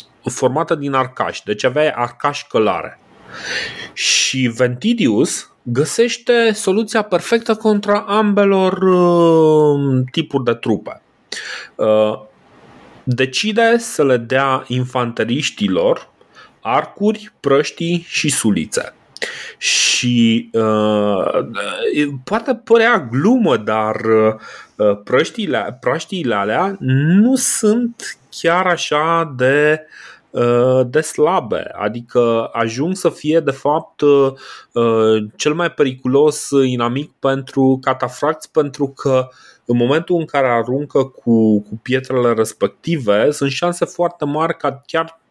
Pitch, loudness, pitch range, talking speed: 145 Hz, -16 LUFS, 125-175 Hz, 100 wpm